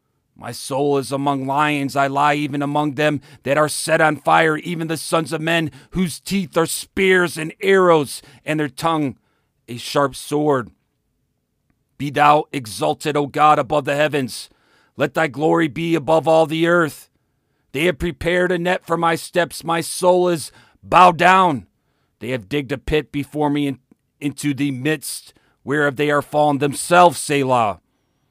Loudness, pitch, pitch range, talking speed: -18 LUFS, 150 Hz, 140-165 Hz, 165 wpm